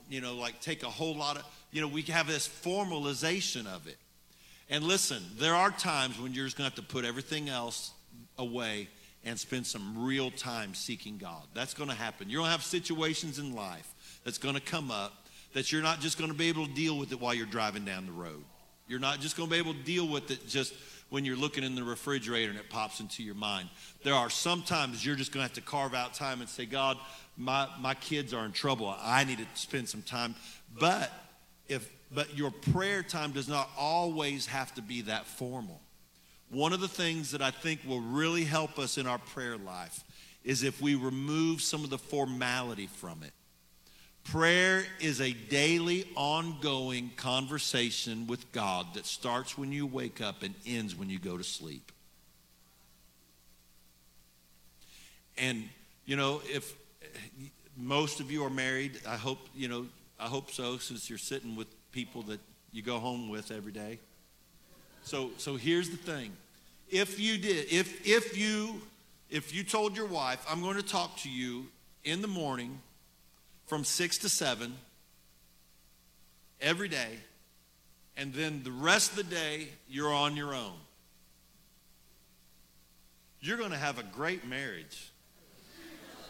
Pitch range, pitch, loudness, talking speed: 110-150 Hz, 130 Hz, -33 LUFS, 175 wpm